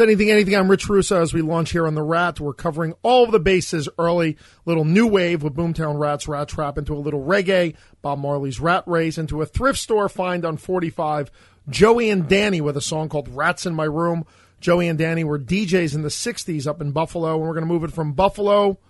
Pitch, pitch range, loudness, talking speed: 165 Hz, 155-190 Hz, -20 LUFS, 225 wpm